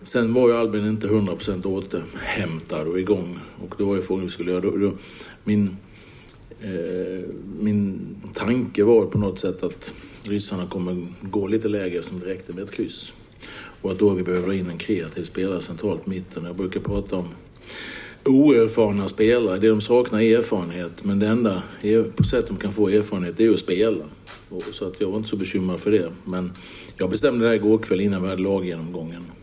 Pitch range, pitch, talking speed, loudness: 90-110 Hz, 100 Hz, 190 wpm, -22 LUFS